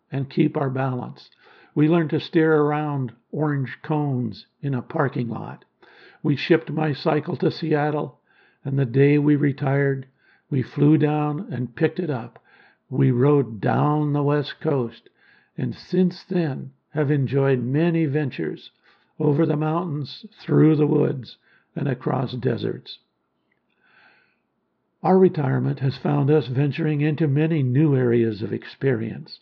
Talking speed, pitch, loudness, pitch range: 135 wpm, 145 Hz, -22 LUFS, 135-155 Hz